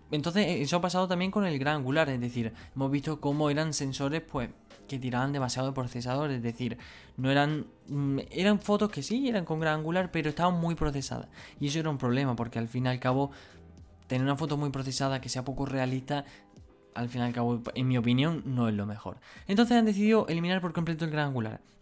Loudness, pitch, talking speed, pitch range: -30 LUFS, 140 Hz, 215 wpm, 125-160 Hz